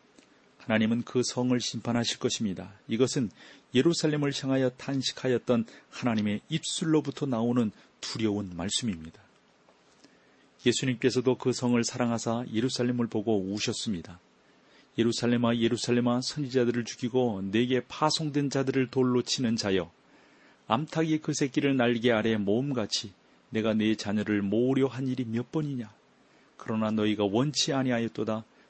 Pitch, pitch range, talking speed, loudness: 120 Hz, 110-135 Hz, 320 characters per minute, -28 LUFS